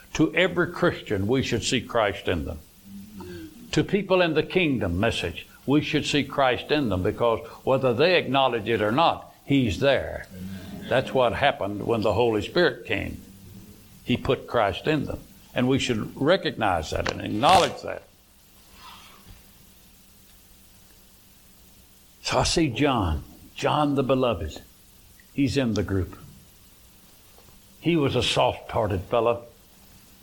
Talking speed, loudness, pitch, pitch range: 135 wpm, -24 LUFS, 120 Hz, 100-140 Hz